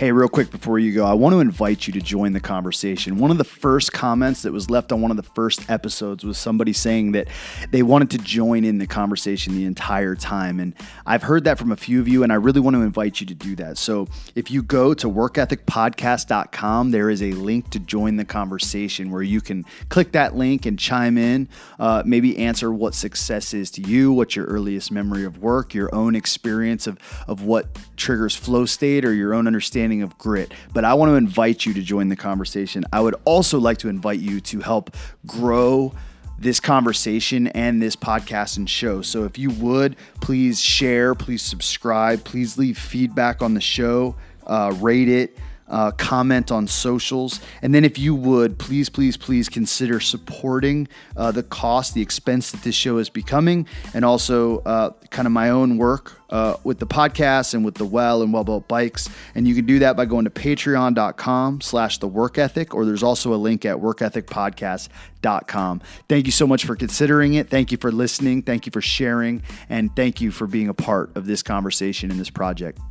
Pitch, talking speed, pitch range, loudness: 115 Hz, 205 wpm, 105-125 Hz, -20 LUFS